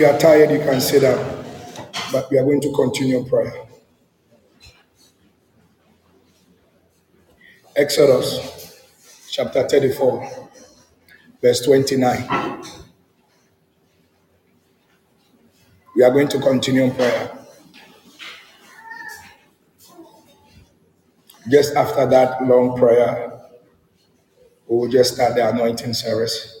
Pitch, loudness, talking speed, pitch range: 130 Hz, -17 LUFS, 85 wpm, 120-150 Hz